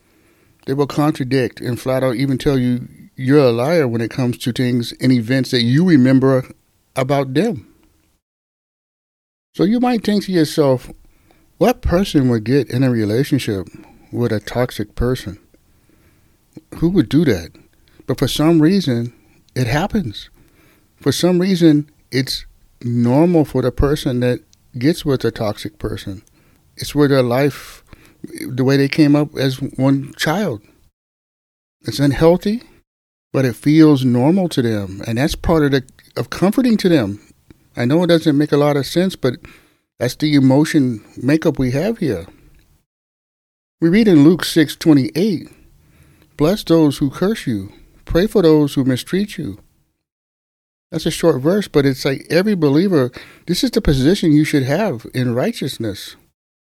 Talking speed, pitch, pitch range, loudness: 155 wpm, 140 Hz, 125-160 Hz, -16 LUFS